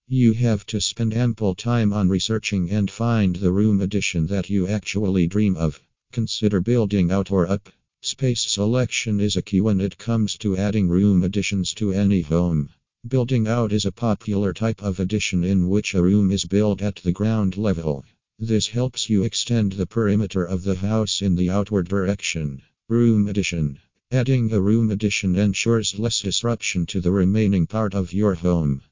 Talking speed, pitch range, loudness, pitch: 175 wpm, 95-110 Hz, -21 LUFS, 100 Hz